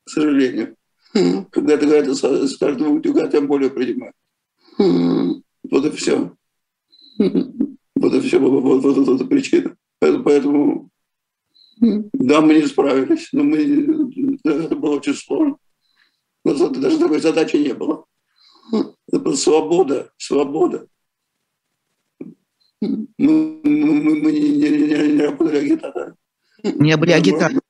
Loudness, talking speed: -17 LUFS, 115 wpm